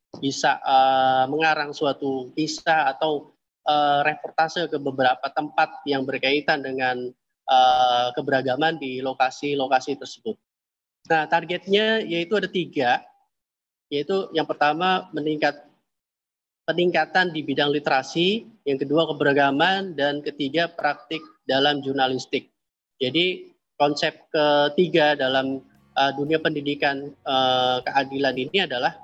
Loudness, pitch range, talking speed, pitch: -22 LUFS, 135-160 Hz, 105 wpm, 145 Hz